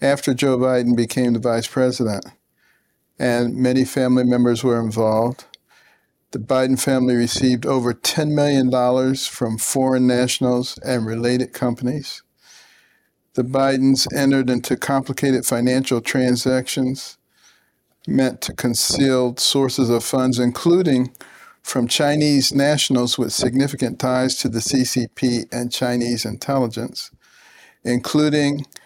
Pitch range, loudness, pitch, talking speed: 120-135 Hz, -19 LUFS, 130 Hz, 110 wpm